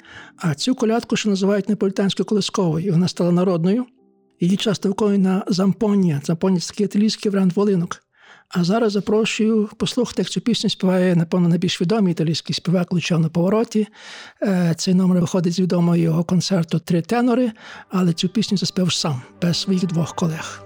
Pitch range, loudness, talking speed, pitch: 175-210 Hz, -20 LUFS, 150 wpm, 185 Hz